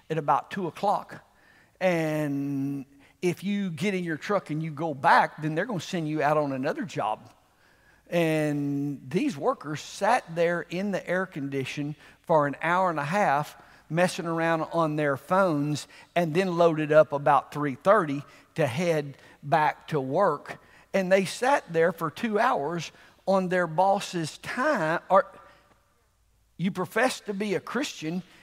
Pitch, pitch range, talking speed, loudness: 165 Hz, 145-185 Hz, 155 wpm, -27 LUFS